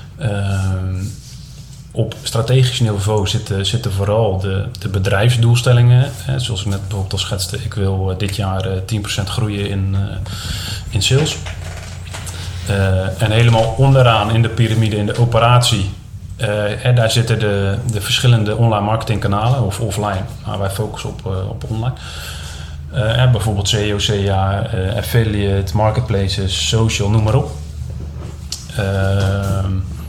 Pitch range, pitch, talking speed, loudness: 95-115 Hz, 105 Hz, 130 wpm, -16 LUFS